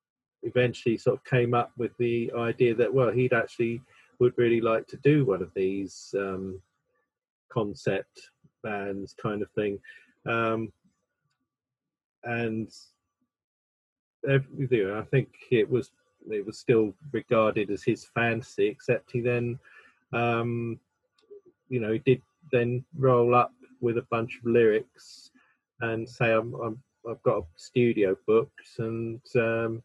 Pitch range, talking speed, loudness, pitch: 115-130 Hz, 135 wpm, -27 LUFS, 120 Hz